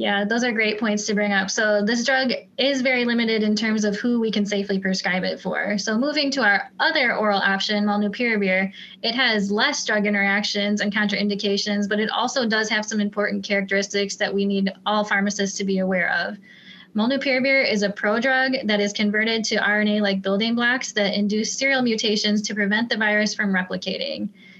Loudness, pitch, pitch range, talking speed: -21 LUFS, 210 Hz, 200-225 Hz, 190 wpm